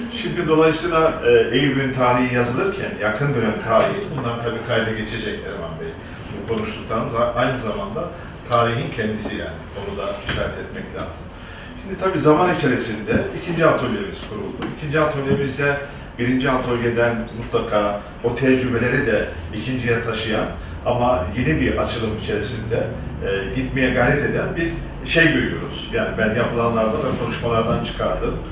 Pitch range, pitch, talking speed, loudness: 110-140 Hz, 120 Hz, 130 wpm, -21 LUFS